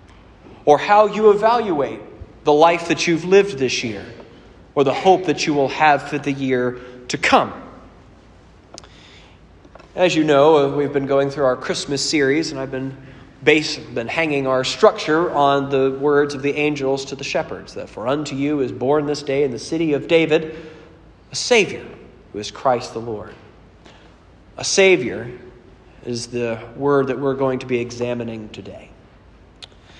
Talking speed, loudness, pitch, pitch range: 165 wpm, -18 LUFS, 140 Hz, 120-150 Hz